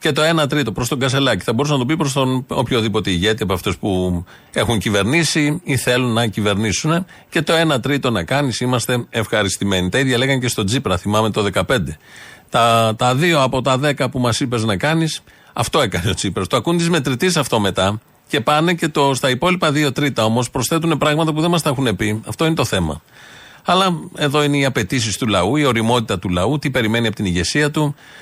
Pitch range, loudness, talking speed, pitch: 110-150 Hz, -17 LUFS, 215 wpm, 130 Hz